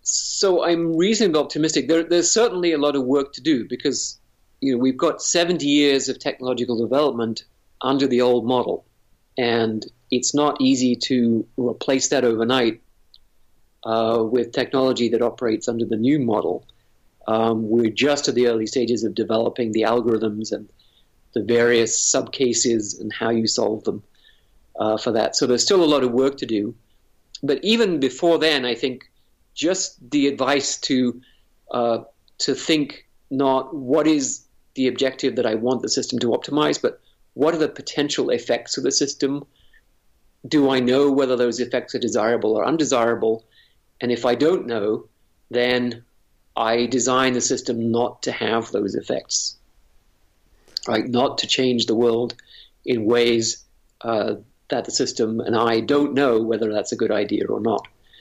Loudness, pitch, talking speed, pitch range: -21 LUFS, 125 Hz, 165 wpm, 115-140 Hz